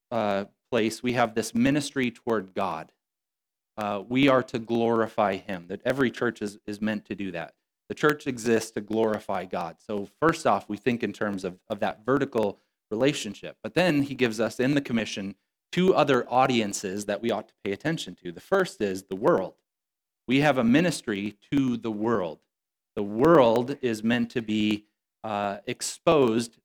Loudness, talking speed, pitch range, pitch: -26 LUFS, 180 wpm, 105-125 Hz, 115 Hz